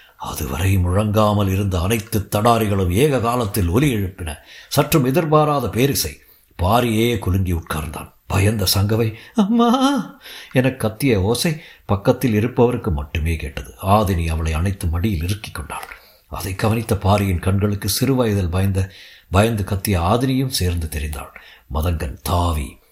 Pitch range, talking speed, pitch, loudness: 90-120 Hz, 115 wpm, 100 Hz, -19 LUFS